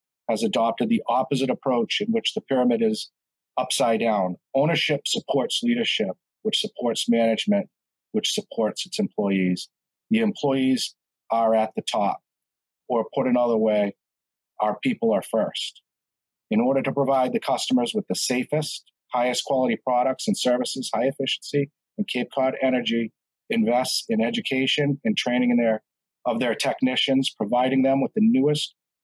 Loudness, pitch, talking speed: -24 LUFS, 135 Hz, 145 wpm